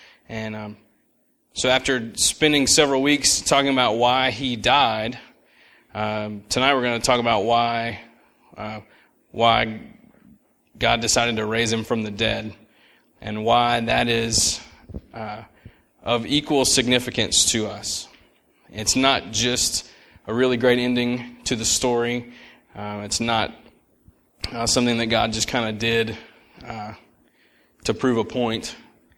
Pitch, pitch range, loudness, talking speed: 115 Hz, 110-125 Hz, -20 LUFS, 135 wpm